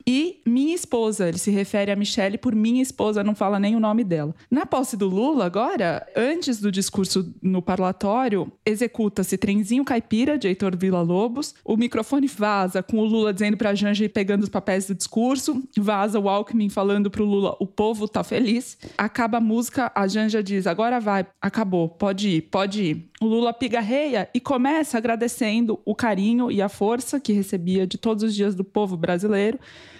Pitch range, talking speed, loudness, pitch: 200-235 Hz, 185 wpm, -23 LUFS, 210 Hz